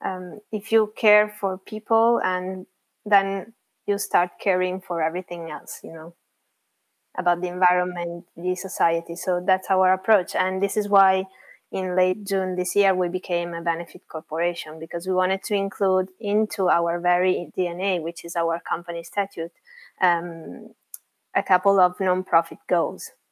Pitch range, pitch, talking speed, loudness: 175-195 Hz, 185 Hz, 150 wpm, -23 LUFS